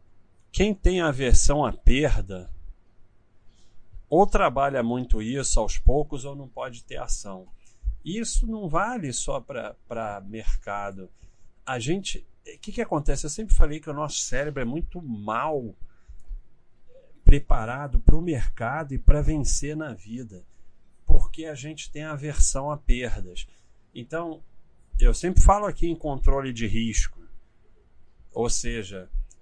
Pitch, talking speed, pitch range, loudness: 125 Hz, 135 wpm, 100-155 Hz, -27 LUFS